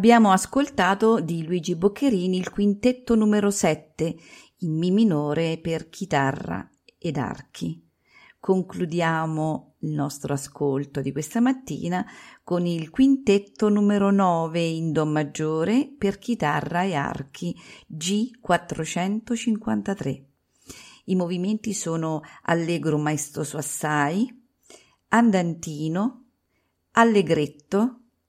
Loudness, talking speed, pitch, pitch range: -24 LUFS, 95 wpm, 180 Hz, 155-215 Hz